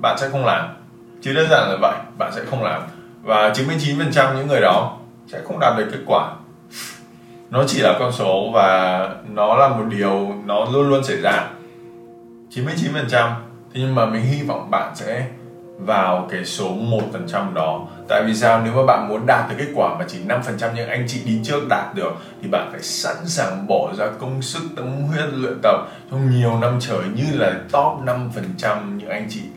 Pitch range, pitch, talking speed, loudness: 110-135 Hz, 120 Hz, 215 wpm, -19 LUFS